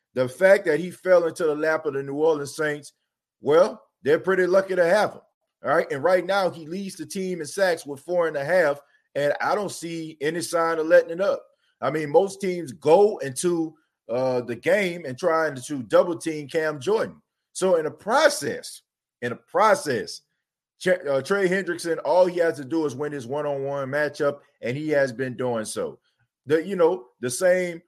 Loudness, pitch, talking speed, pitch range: -23 LUFS, 165 Hz, 205 wpm, 145-185 Hz